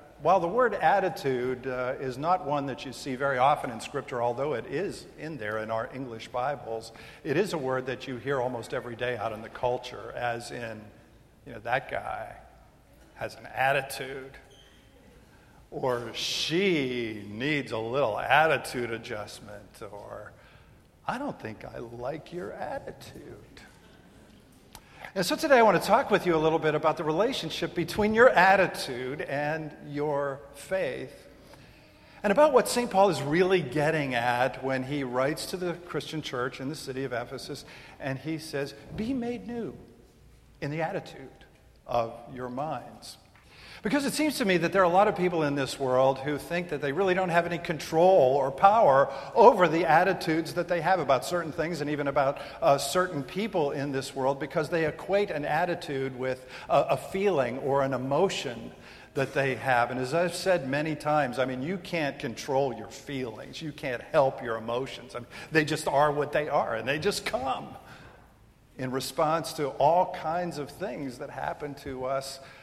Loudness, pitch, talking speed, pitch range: -28 LUFS, 140 Hz, 180 wpm, 130-170 Hz